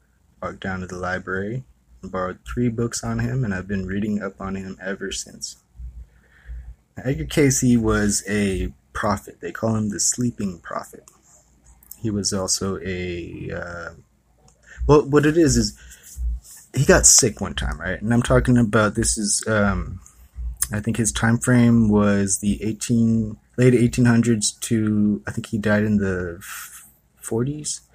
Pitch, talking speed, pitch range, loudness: 105 Hz, 160 wpm, 90-115 Hz, -21 LUFS